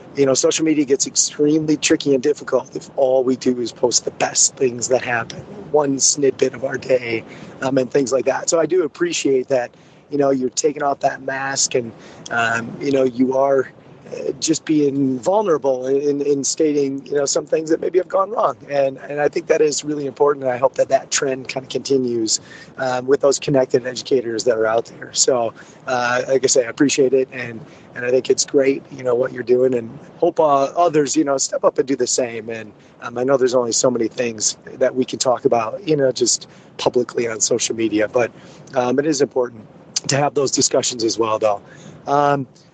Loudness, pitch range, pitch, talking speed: -18 LUFS, 130-155 Hz, 135 Hz, 215 wpm